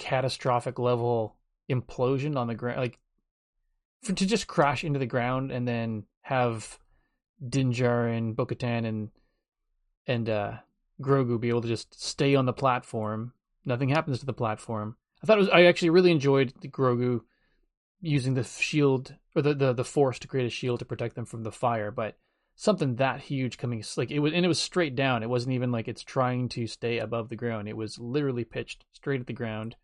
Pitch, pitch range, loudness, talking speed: 125 Hz, 115-140 Hz, -28 LUFS, 195 wpm